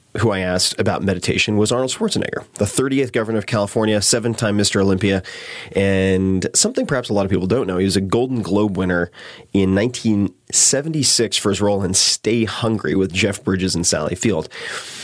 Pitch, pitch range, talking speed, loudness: 100 Hz, 95-115 Hz, 185 wpm, -18 LUFS